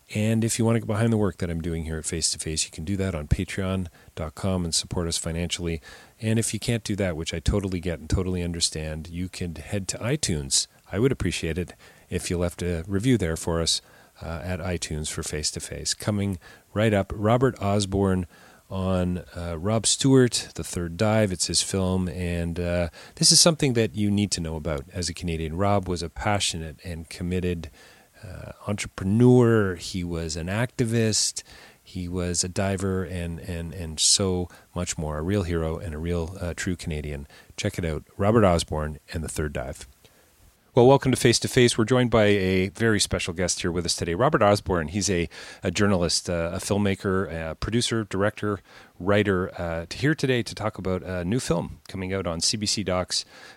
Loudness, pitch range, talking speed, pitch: -25 LUFS, 85-105 Hz, 200 wpm, 90 Hz